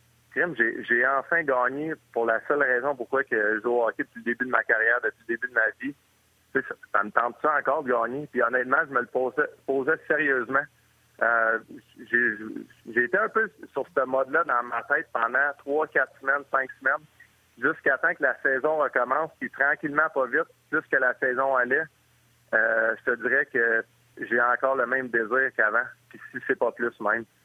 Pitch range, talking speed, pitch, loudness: 115-145 Hz, 190 wpm, 125 Hz, -25 LUFS